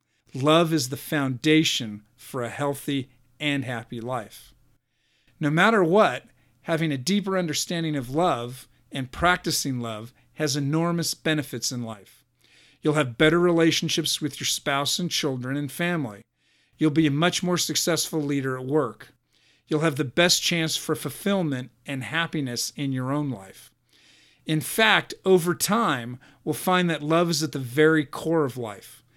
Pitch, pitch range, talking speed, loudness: 150 Hz, 130-165 Hz, 155 wpm, -24 LUFS